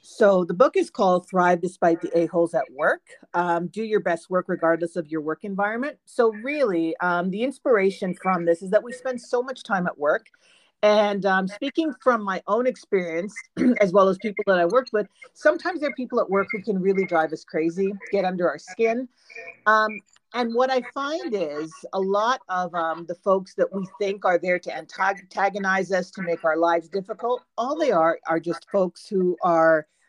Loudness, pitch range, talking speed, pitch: -23 LUFS, 175-230 Hz, 205 wpm, 195 Hz